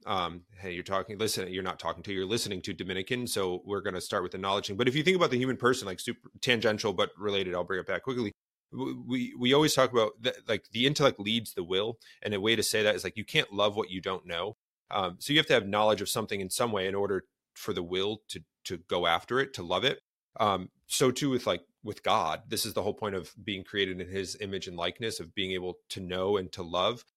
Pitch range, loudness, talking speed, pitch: 95-125 Hz, -30 LUFS, 265 wpm, 100 Hz